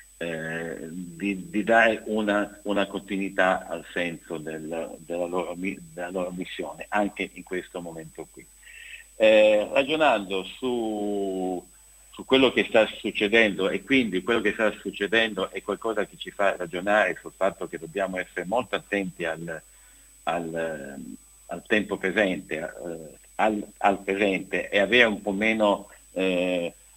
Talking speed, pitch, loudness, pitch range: 140 wpm, 100 Hz, -25 LUFS, 90-105 Hz